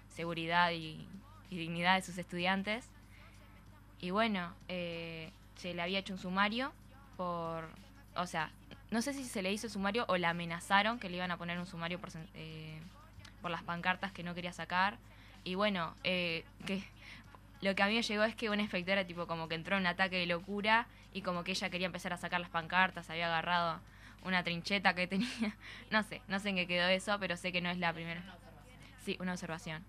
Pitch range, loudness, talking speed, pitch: 165-195 Hz, -36 LUFS, 205 wpm, 175 Hz